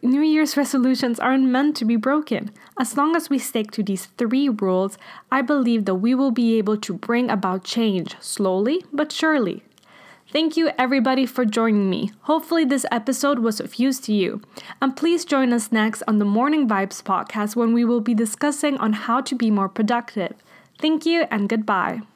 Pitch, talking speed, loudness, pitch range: 240 Hz, 190 wpm, -21 LUFS, 215-275 Hz